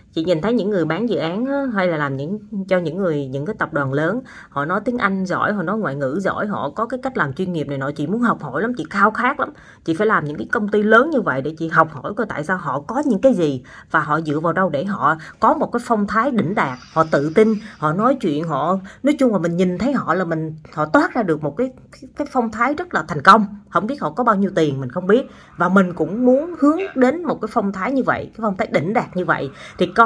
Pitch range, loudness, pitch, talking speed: 160-235 Hz, -19 LUFS, 195 Hz, 290 wpm